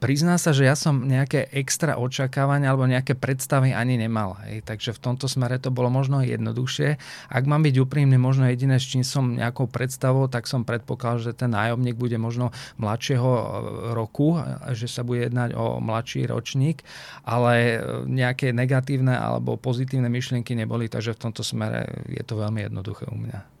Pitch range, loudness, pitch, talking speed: 115-135 Hz, -24 LUFS, 125 Hz, 170 wpm